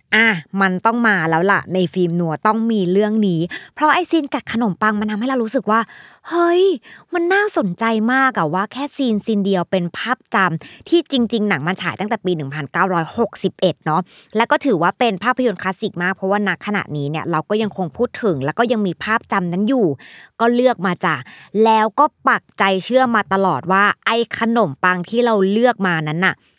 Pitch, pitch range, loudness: 210 Hz, 185-235 Hz, -18 LUFS